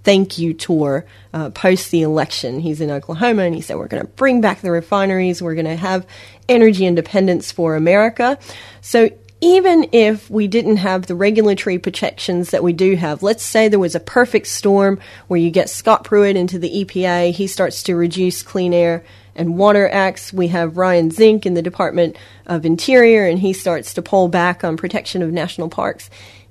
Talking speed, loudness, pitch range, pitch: 190 wpm, -16 LUFS, 170-205 Hz, 185 Hz